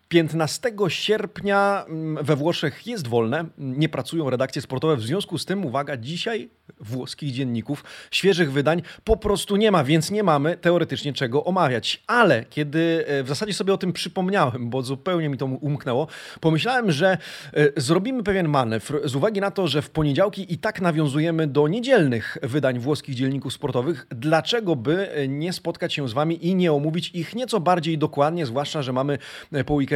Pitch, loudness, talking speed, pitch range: 155 Hz, -23 LUFS, 165 wpm, 140-180 Hz